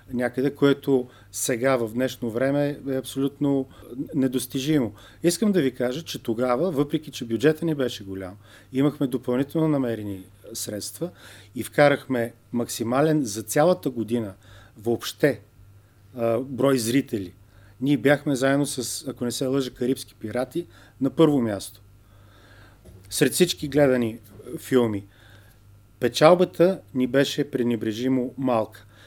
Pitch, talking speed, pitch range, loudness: 125 Hz, 115 wpm, 105-140 Hz, -24 LUFS